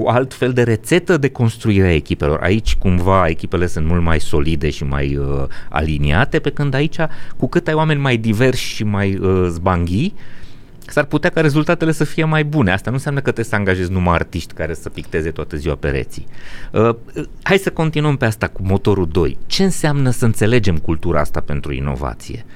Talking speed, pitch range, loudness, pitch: 195 wpm, 85-140 Hz, -17 LUFS, 105 Hz